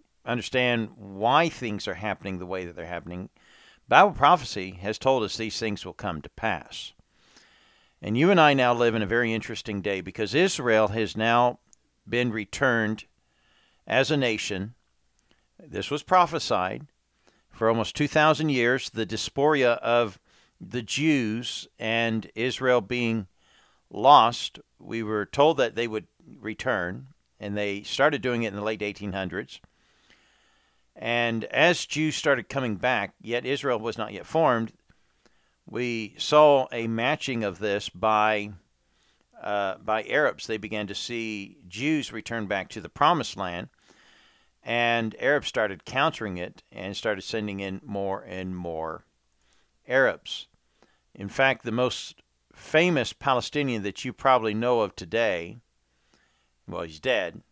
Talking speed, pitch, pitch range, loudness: 140 wpm, 110 Hz, 100-125 Hz, -25 LUFS